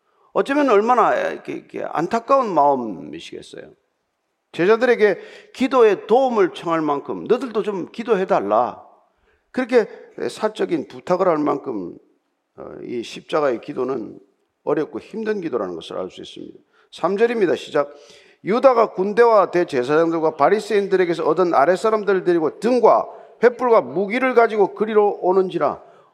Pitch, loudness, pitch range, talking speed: 225 Hz, -19 LUFS, 190-270 Hz, 305 characters per minute